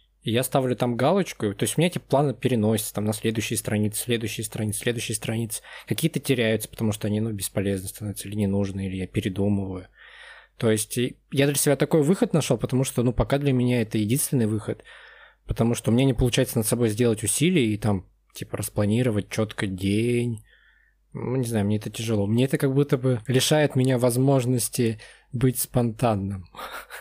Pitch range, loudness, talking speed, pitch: 105-130 Hz, -24 LUFS, 185 wpm, 115 Hz